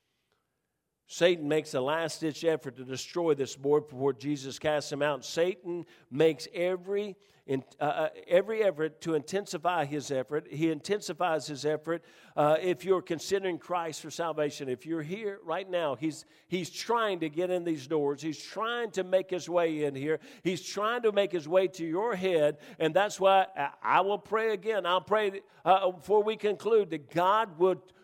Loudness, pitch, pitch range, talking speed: -30 LUFS, 170 Hz, 150-190 Hz, 175 wpm